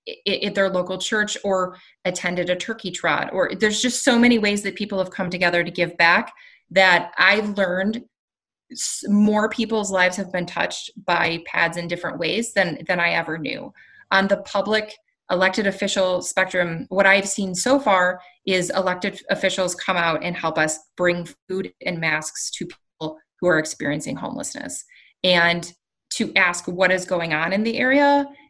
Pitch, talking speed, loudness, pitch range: 185 Hz, 170 wpm, -21 LUFS, 175-205 Hz